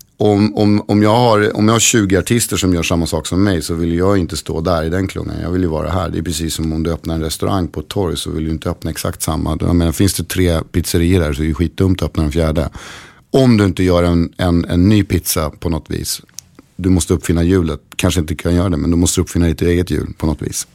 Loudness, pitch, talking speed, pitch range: -16 LUFS, 90 Hz, 280 wpm, 80-95 Hz